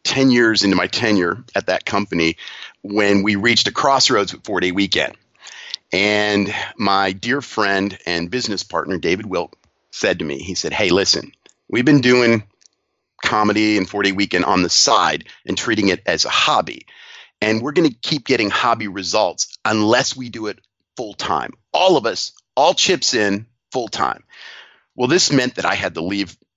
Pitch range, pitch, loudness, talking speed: 100-125 Hz, 105 Hz, -17 LUFS, 180 wpm